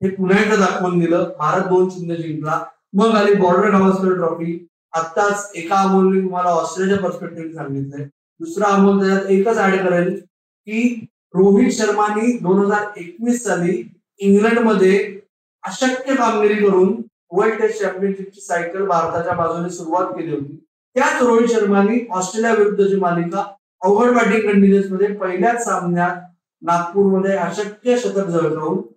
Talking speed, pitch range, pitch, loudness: 110 wpm, 175-210 Hz, 190 Hz, -17 LUFS